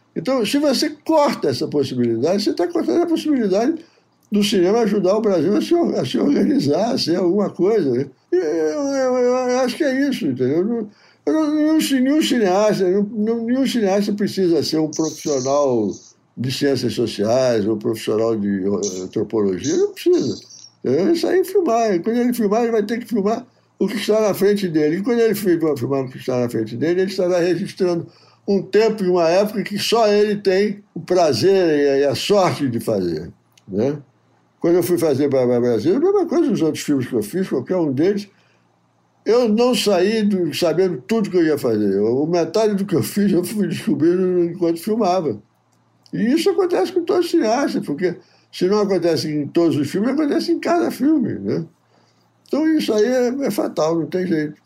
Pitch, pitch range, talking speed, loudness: 195 Hz, 160-250 Hz, 190 wpm, -19 LUFS